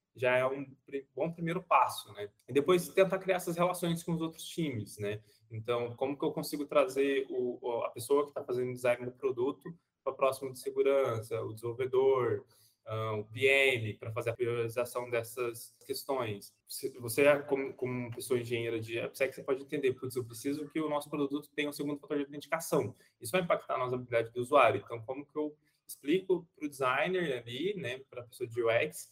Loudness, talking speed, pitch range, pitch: -33 LUFS, 195 wpm, 120-160 Hz, 135 Hz